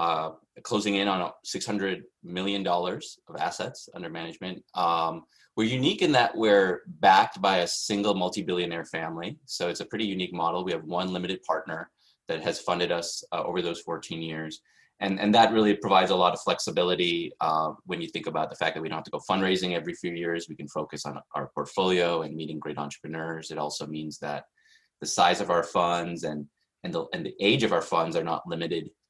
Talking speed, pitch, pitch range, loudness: 205 wpm, 90 Hz, 80-95 Hz, -27 LUFS